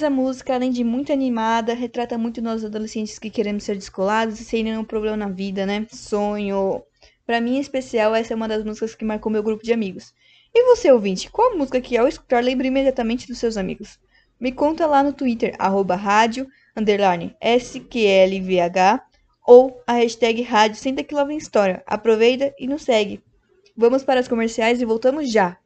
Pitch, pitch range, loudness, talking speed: 230 Hz, 215-255 Hz, -20 LUFS, 180 wpm